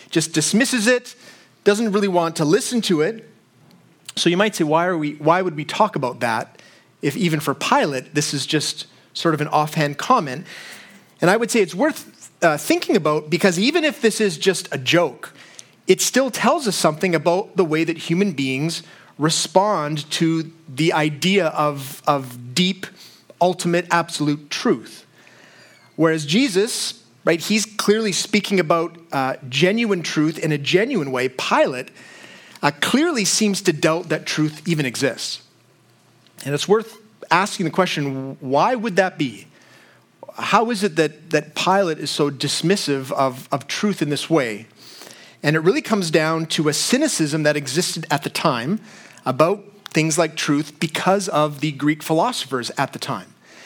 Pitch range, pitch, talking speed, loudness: 150-200 Hz, 165 Hz, 165 wpm, -20 LUFS